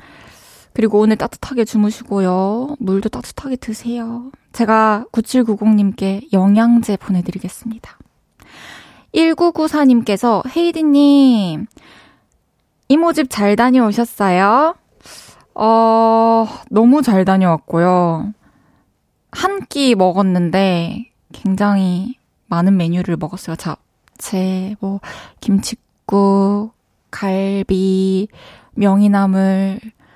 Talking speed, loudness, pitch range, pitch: 185 characters per minute, -15 LUFS, 190-235 Hz, 210 Hz